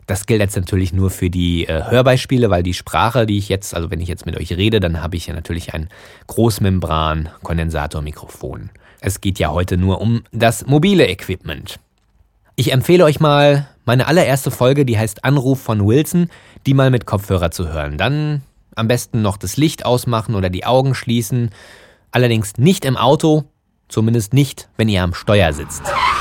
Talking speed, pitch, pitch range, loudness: 180 wpm, 110 Hz, 90-130 Hz, -16 LUFS